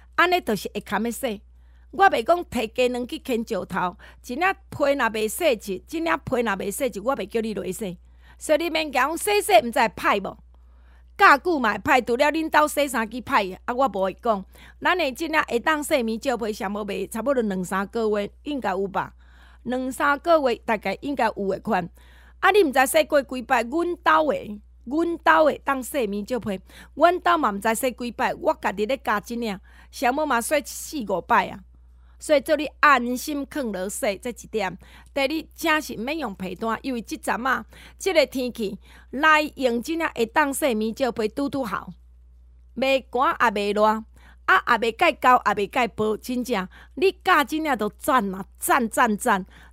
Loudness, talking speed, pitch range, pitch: -23 LUFS, 260 characters per minute, 210-300 Hz, 250 Hz